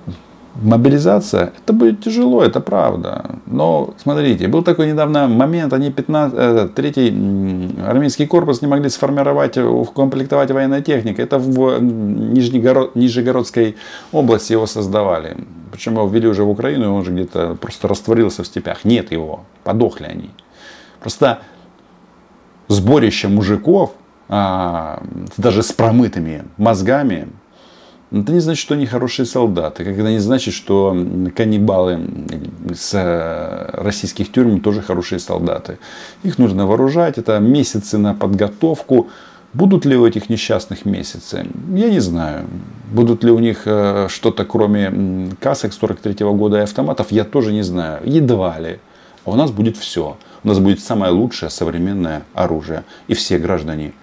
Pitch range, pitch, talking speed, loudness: 95-130 Hz, 110 Hz, 135 wpm, -16 LUFS